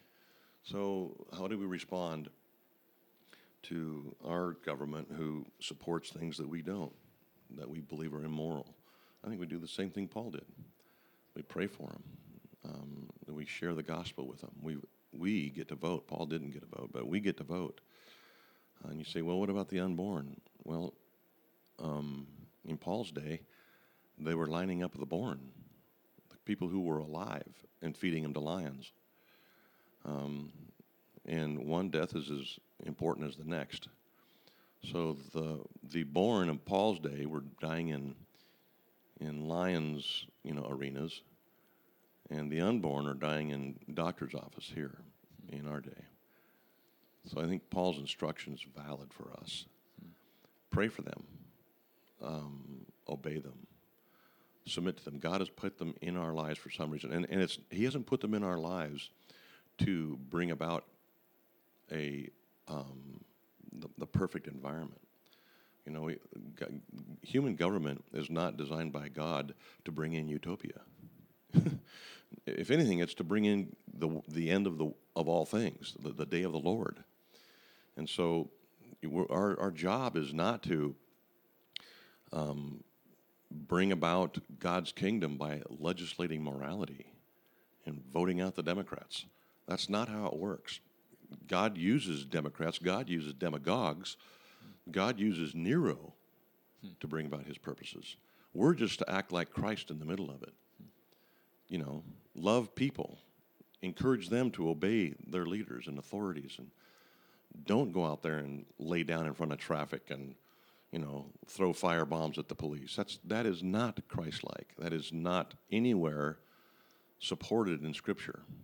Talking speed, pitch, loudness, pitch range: 150 wpm, 80 Hz, -38 LUFS, 75-85 Hz